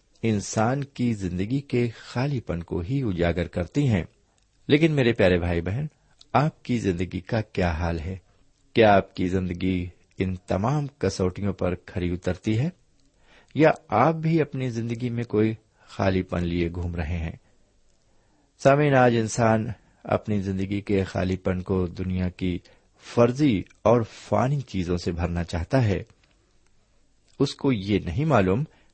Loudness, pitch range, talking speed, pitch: -25 LUFS, 90-125 Hz, 145 wpm, 100 Hz